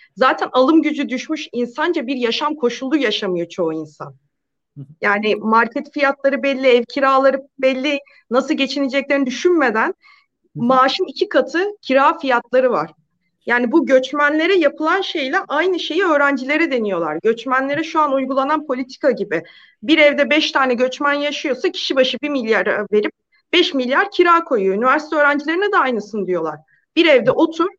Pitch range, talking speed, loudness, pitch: 240-310 Hz, 140 wpm, -17 LUFS, 275 Hz